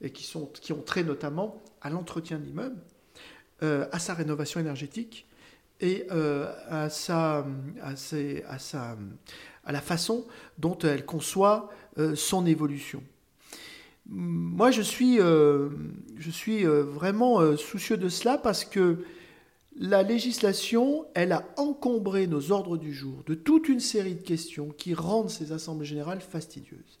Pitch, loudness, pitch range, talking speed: 165 Hz, -28 LUFS, 150-205 Hz, 150 wpm